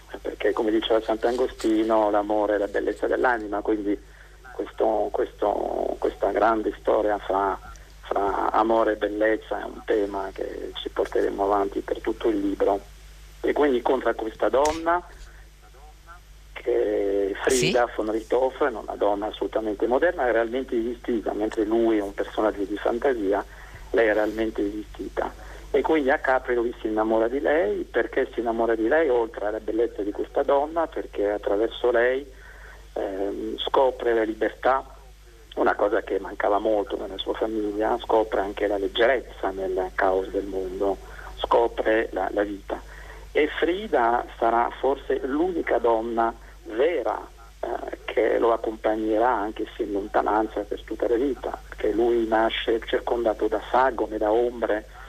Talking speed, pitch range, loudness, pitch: 145 wpm, 105-155 Hz, -25 LUFS, 115 Hz